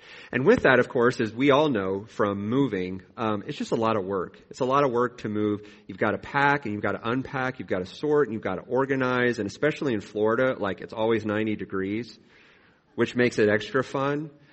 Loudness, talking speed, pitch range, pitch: -25 LUFS, 235 wpm, 105-135 Hz, 115 Hz